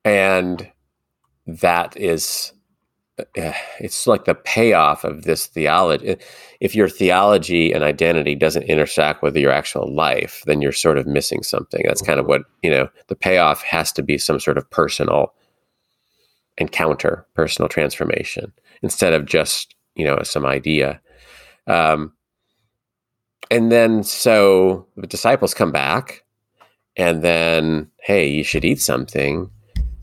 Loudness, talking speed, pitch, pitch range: -18 LUFS, 135 wpm, 85 Hz, 75-95 Hz